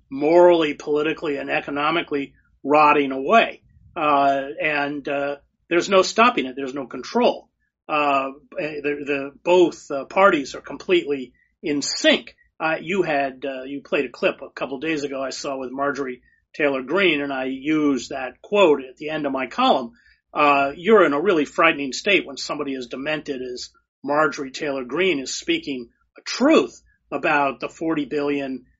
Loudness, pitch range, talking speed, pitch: -21 LUFS, 135-155 Hz, 165 wpm, 145 Hz